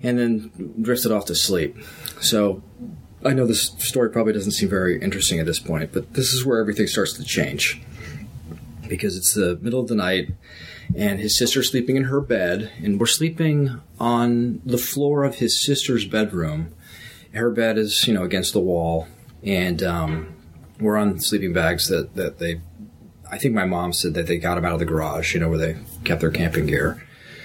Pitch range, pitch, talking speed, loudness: 85-125 Hz, 105 Hz, 195 wpm, -21 LUFS